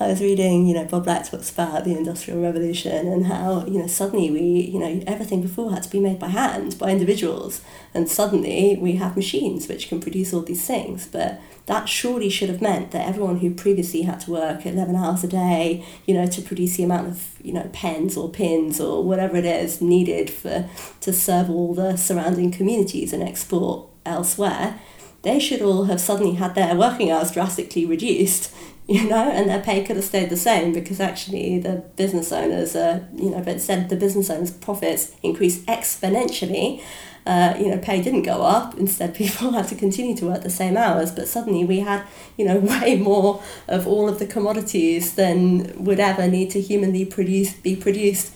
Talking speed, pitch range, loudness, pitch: 200 wpm, 175-200 Hz, -21 LUFS, 185 Hz